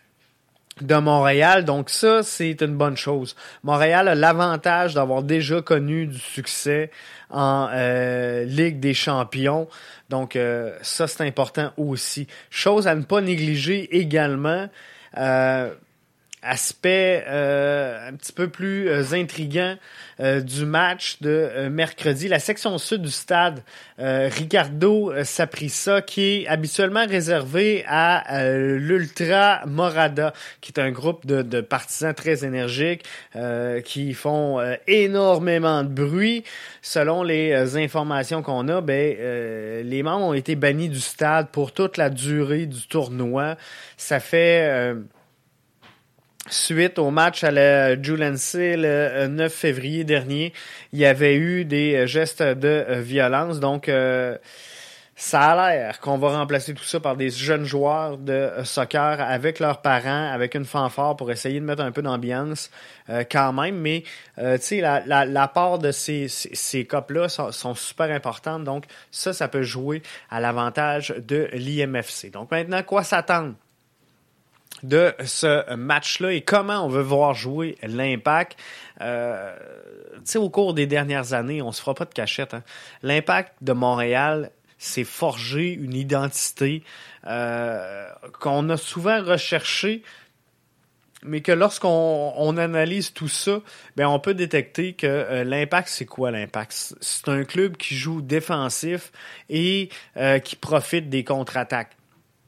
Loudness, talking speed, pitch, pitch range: -22 LUFS, 145 wpm, 150 Hz, 135-165 Hz